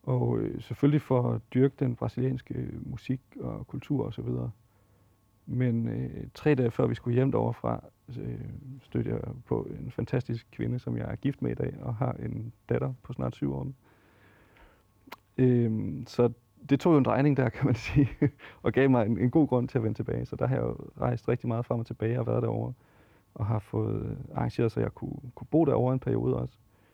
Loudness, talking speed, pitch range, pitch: -29 LUFS, 205 wpm, 110-130 Hz, 120 Hz